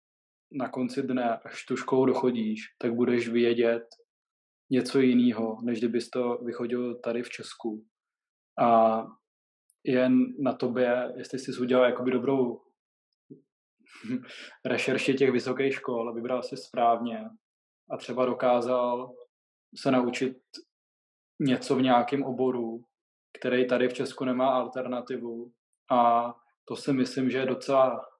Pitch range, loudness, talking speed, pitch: 120-130 Hz, -27 LUFS, 125 wpm, 125 Hz